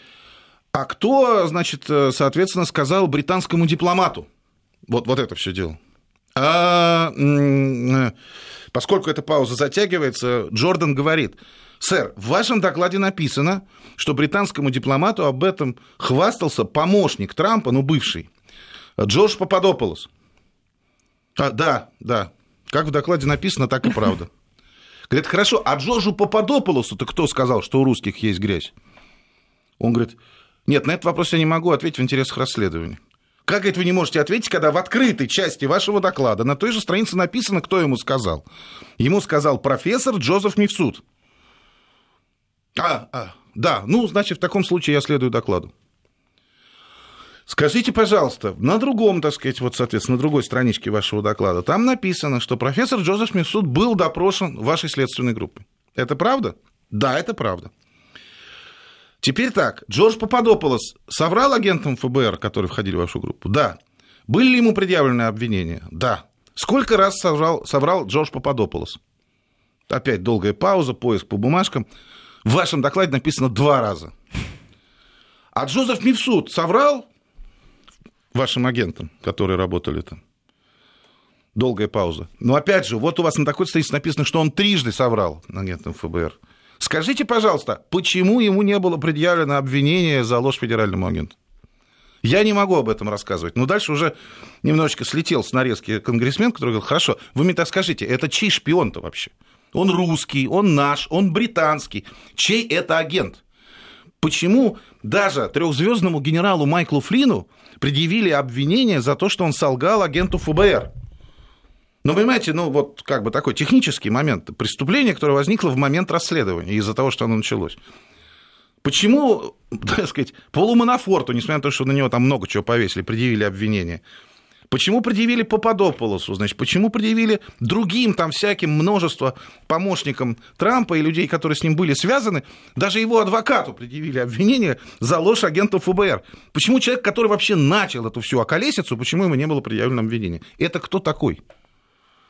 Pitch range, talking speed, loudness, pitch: 125-195 Hz, 145 wpm, -19 LUFS, 155 Hz